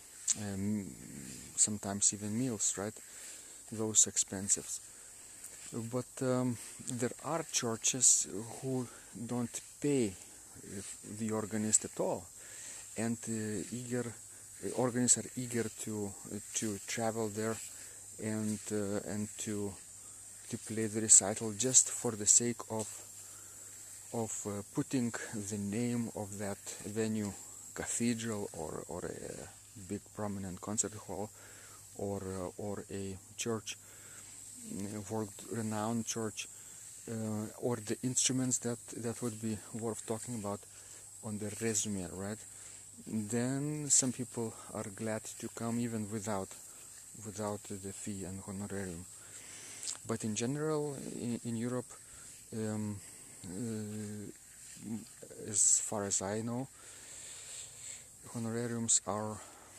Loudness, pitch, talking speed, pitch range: -35 LUFS, 110 Hz, 115 wpm, 100-115 Hz